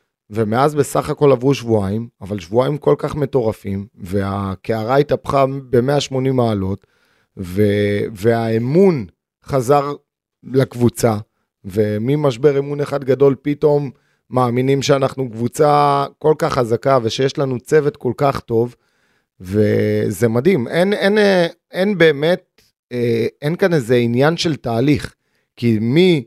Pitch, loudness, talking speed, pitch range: 130 Hz, -17 LUFS, 110 wpm, 115-145 Hz